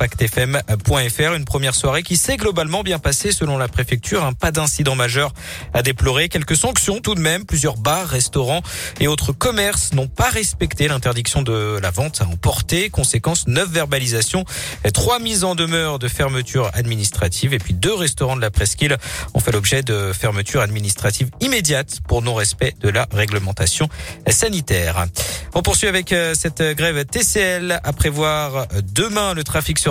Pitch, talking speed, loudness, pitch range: 135 Hz, 160 wpm, -18 LUFS, 110-160 Hz